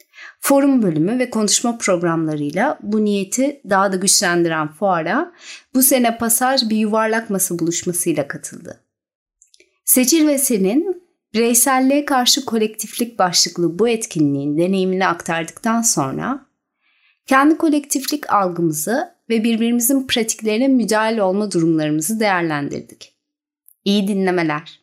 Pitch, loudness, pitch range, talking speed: 220 Hz, -17 LUFS, 180-265 Hz, 105 wpm